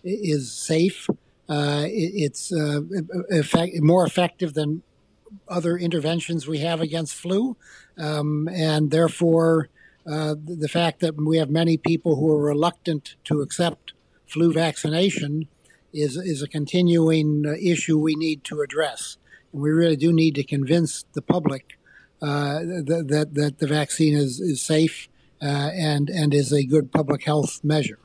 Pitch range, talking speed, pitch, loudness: 150-170 Hz, 150 wpm, 160 Hz, -23 LUFS